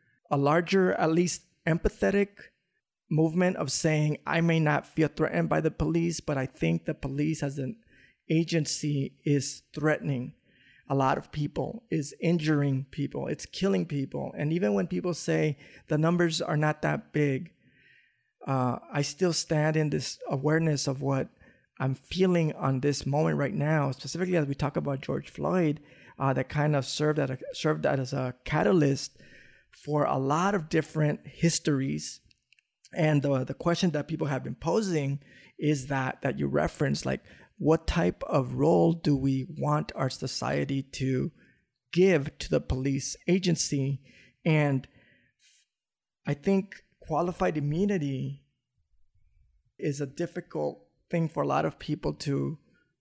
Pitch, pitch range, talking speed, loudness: 150 Hz, 135-165 Hz, 150 wpm, -28 LUFS